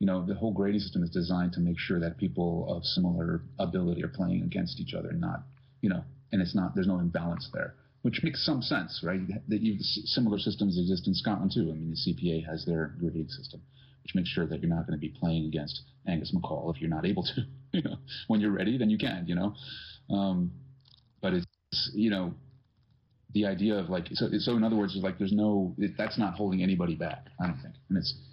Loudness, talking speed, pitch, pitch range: -31 LUFS, 235 wpm, 100 Hz, 90-120 Hz